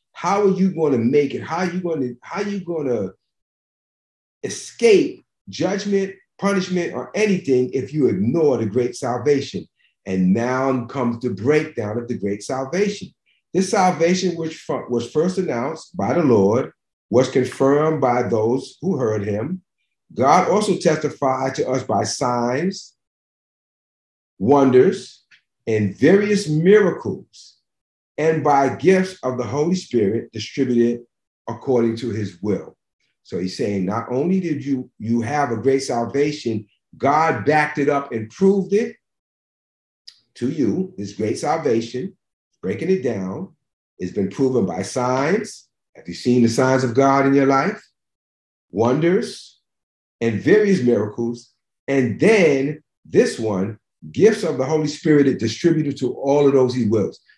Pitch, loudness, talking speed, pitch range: 135 Hz, -20 LUFS, 145 wpm, 120-170 Hz